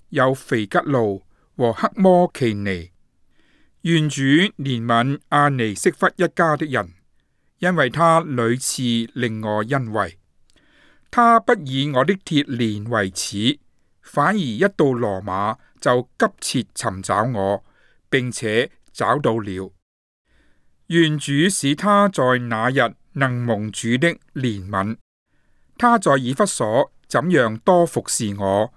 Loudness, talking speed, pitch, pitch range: -20 LUFS, 165 characters per minute, 125 Hz, 110-160 Hz